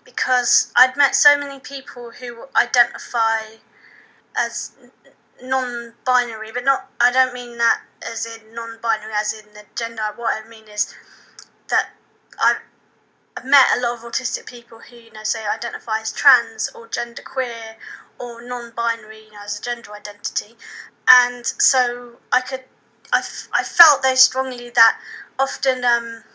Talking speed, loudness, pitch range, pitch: 150 wpm, -19 LUFS, 225-255 Hz, 240 Hz